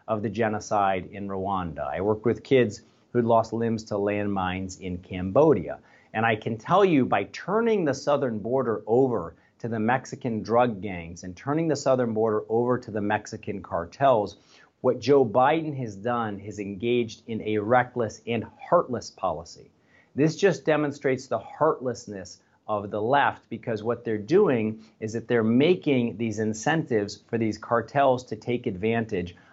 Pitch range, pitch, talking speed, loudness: 105-125 Hz, 115 Hz, 160 wpm, -26 LUFS